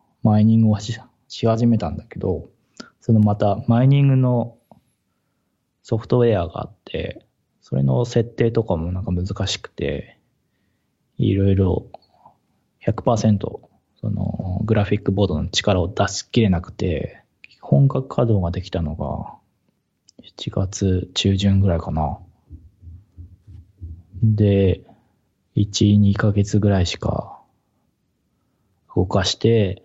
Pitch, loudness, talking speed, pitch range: 100 Hz, -20 LUFS, 210 characters per minute, 95-115 Hz